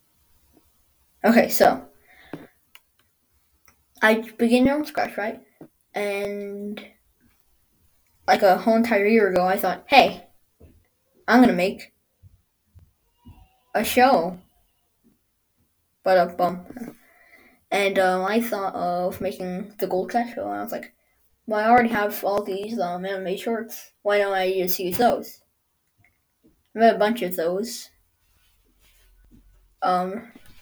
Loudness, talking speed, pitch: -22 LUFS, 120 wpm, 185 Hz